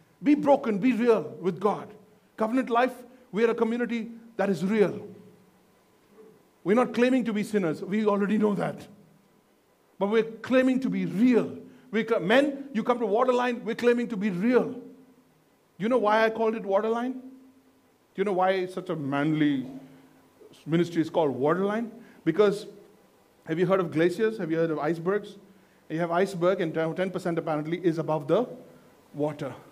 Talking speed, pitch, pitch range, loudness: 165 wpm, 210 Hz, 180-230 Hz, -26 LUFS